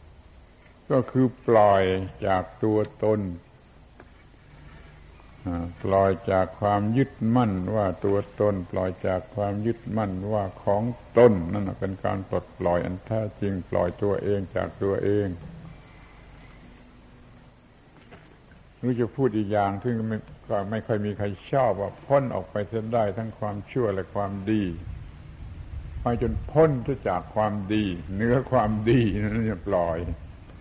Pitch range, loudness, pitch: 95-110 Hz, -26 LUFS, 100 Hz